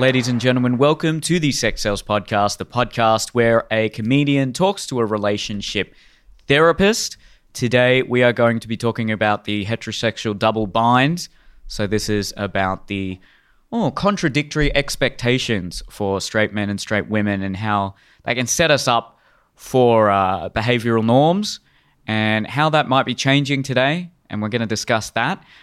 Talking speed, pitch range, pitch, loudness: 160 wpm, 105-135 Hz, 115 Hz, -19 LUFS